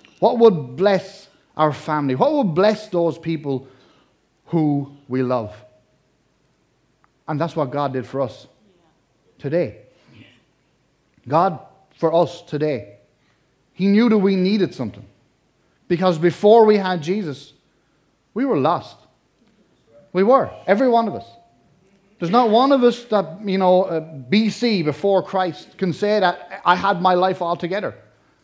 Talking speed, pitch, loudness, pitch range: 135 wpm, 175 Hz, -19 LUFS, 140-195 Hz